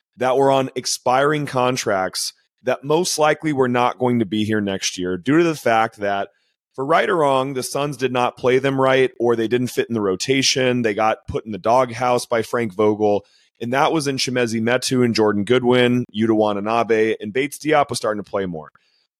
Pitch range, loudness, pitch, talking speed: 110-130 Hz, -19 LUFS, 125 Hz, 205 wpm